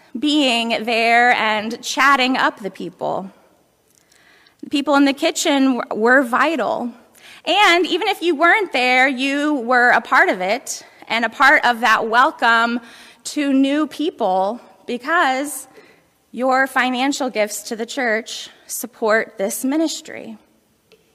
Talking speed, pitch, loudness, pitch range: 130 wpm, 260 Hz, -17 LUFS, 230-290 Hz